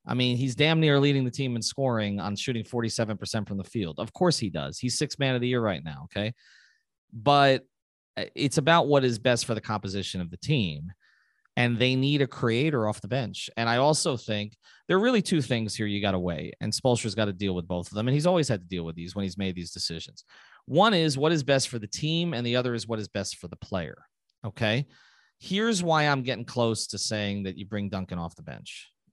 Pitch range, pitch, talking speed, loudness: 100-140 Hz, 115 Hz, 245 wpm, -27 LUFS